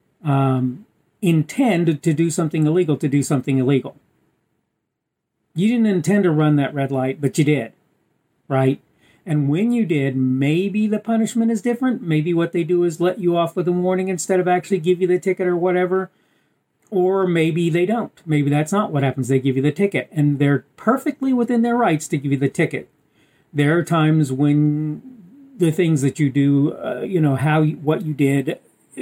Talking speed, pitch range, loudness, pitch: 190 wpm, 145-185 Hz, -19 LUFS, 165 Hz